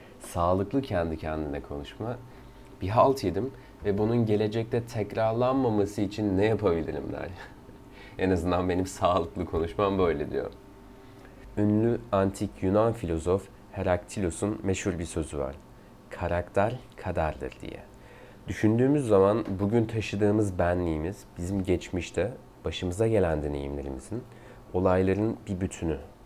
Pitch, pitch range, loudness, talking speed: 100 Hz, 90-115 Hz, -28 LUFS, 105 wpm